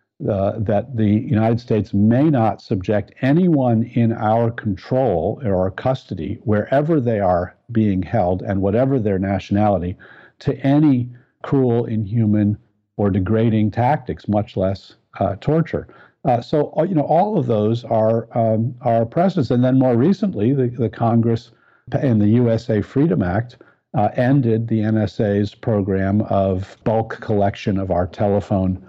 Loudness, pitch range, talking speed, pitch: -19 LUFS, 100-125 Hz, 145 wpm, 110 Hz